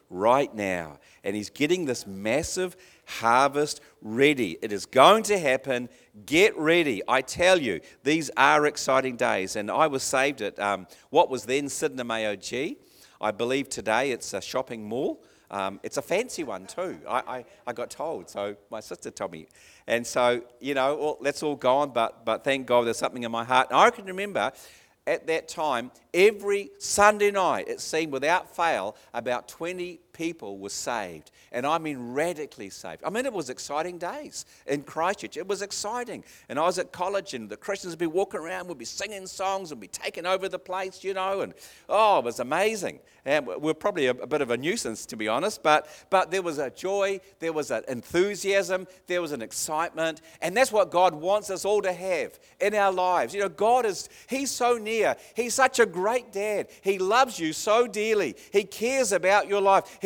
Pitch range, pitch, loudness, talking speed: 130-200 Hz, 175 Hz, -26 LUFS, 200 wpm